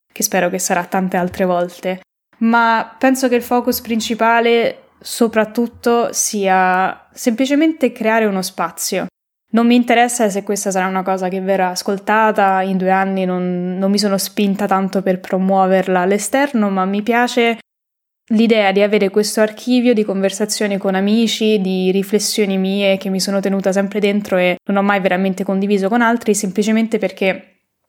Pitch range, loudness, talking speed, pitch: 190-225 Hz, -16 LUFS, 155 wpm, 200 Hz